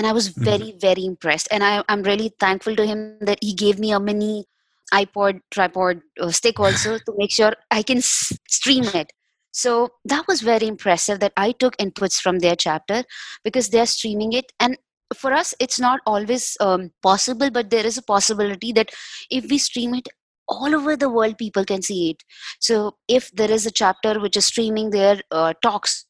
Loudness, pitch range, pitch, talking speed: -20 LUFS, 195-240 Hz, 215 Hz, 200 wpm